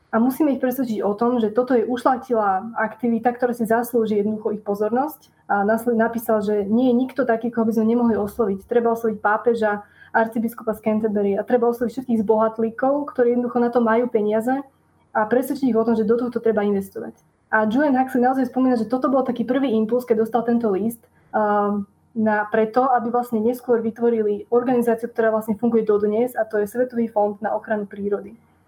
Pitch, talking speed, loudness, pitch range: 230 Hz, 190 wpm, -21 LUFS, 215-245 Hz